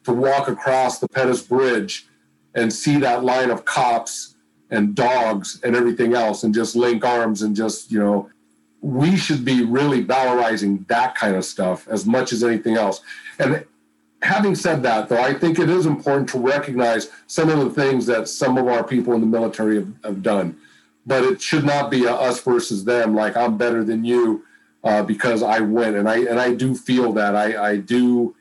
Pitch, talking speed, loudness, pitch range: 120 Hz, 200 wpm, -19 LUFS, 110-130 Hz